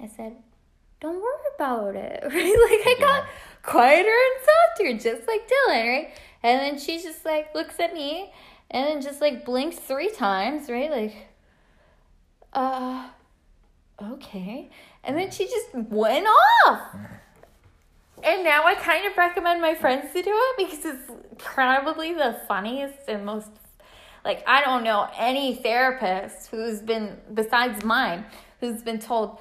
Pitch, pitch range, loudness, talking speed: 275 Hz, 235-330 Hz, -22 LUFS, 150 wpm